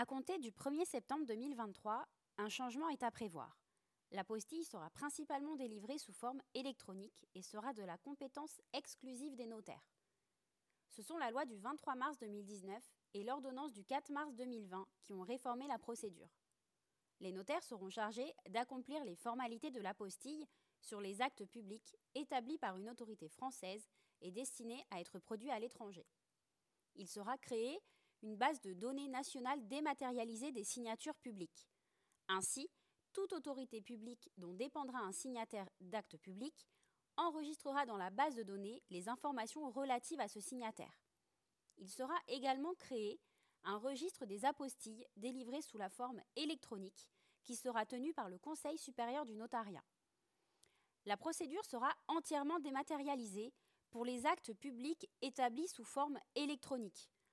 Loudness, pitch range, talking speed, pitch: -46 LUFS, 215-285 Hz, 150 wpm, 250 Hz